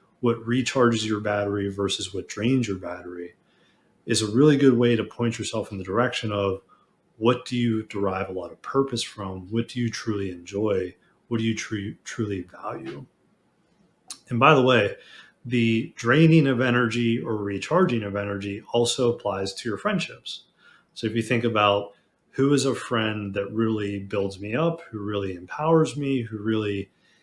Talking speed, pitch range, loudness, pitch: 170 wpm, 100-125 Hz, -24 LUFS, 115 Hz